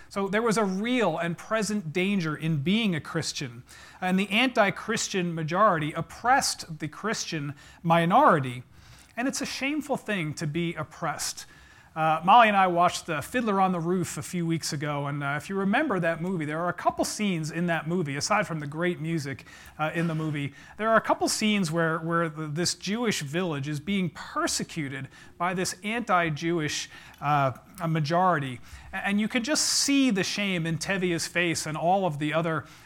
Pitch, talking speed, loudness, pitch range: 170 Hz, 185 wpm, -26 LUFS, 155-205 Hz